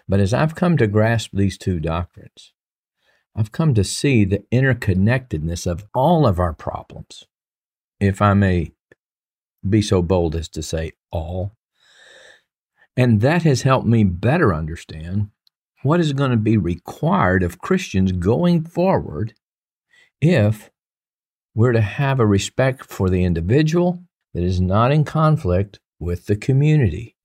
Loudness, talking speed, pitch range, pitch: -19 LUFS, 140 wpm, 90-135 Hz, 105 Hz